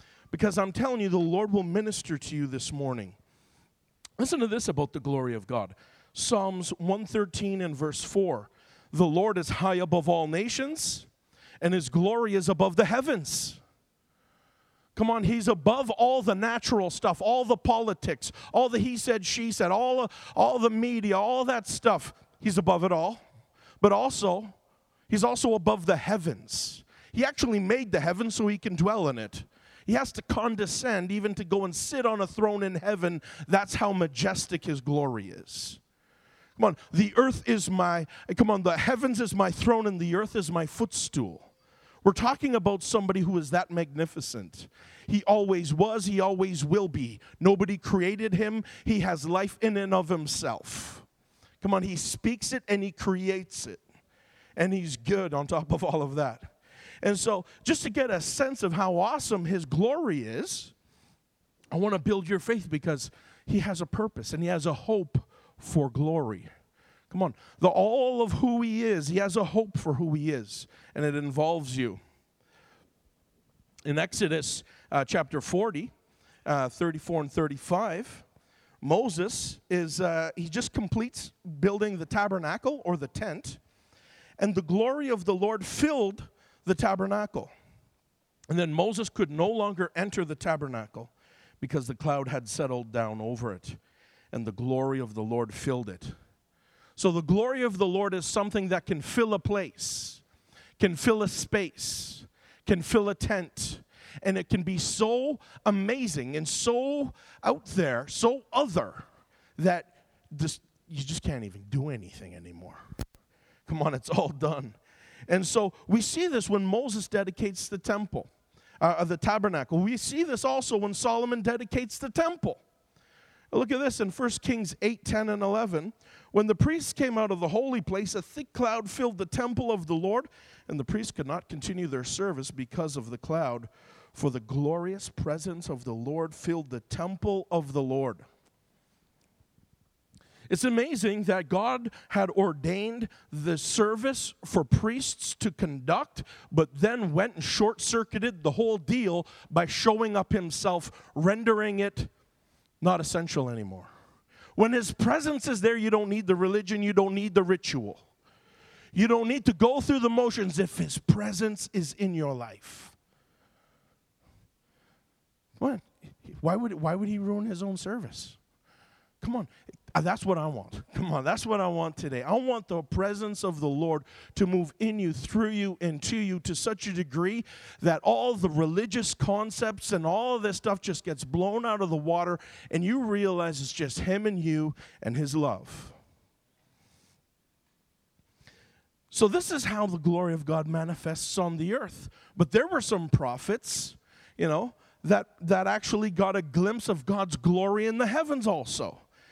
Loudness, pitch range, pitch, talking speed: -28 LUFS, 160-215 Hz, 190 Hz, 165 wpm